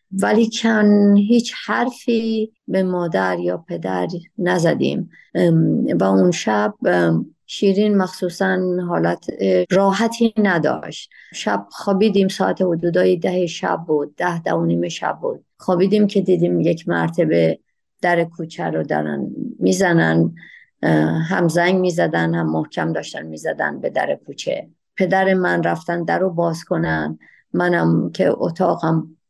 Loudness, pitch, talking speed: -19 LUFS, 175 Hz, 115 wpm